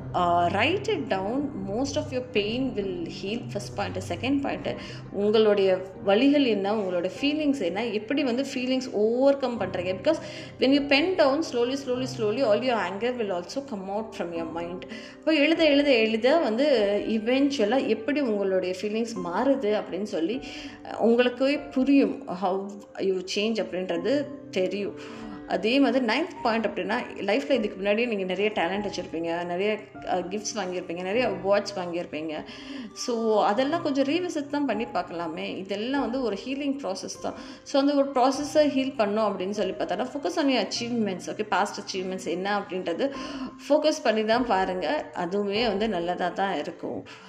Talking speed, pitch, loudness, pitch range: 150 wpm, 220 Hz, -26 LUFS, 195-270 Hz